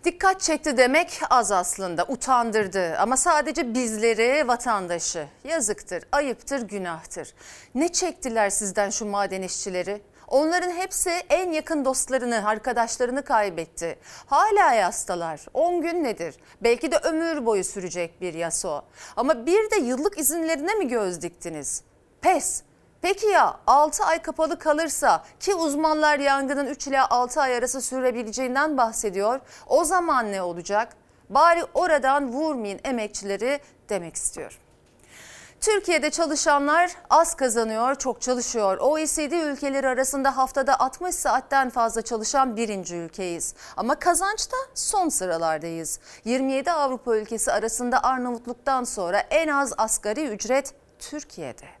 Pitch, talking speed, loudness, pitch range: 260 Hz, 120 wpm, -23 LUFS, 215-310 Hz